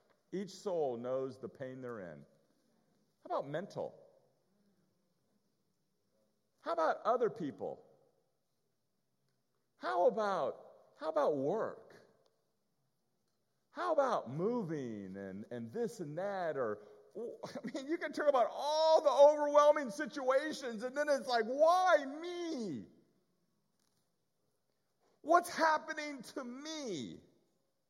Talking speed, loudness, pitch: 105 wpm, -34 LUFS, 280 Hz